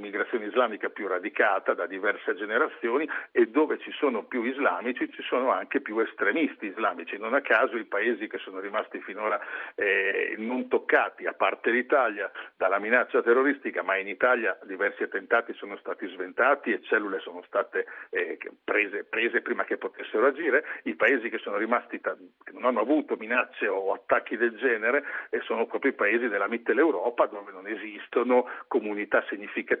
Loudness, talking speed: -27 LUFS, 165 wpm